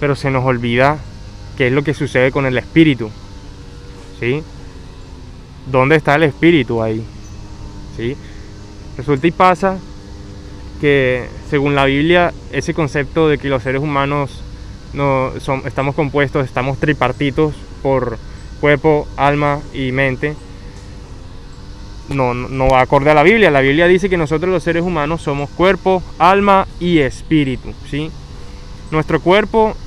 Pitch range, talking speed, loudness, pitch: 105-150 Hz, 135 wpm, -15 LUFS, 135 Hz